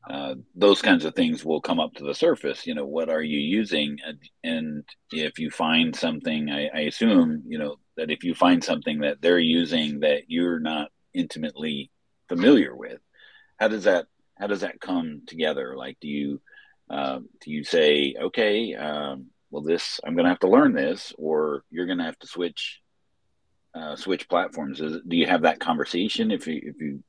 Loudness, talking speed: -24 LUFS, 195 wpm